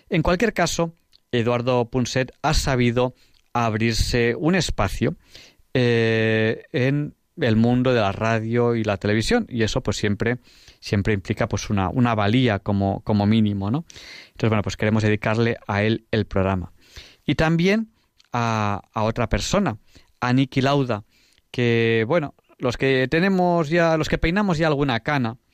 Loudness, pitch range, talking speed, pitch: -22 LUFS, 105-135 Hz, 150 wpm, 120 Hz